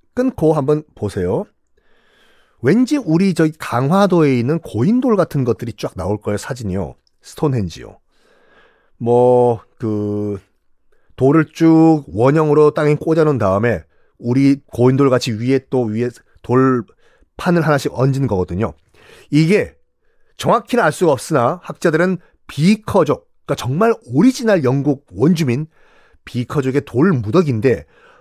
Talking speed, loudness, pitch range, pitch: 270 characters per minute, -16 LUFS, 120-165 Hz, 140 Hz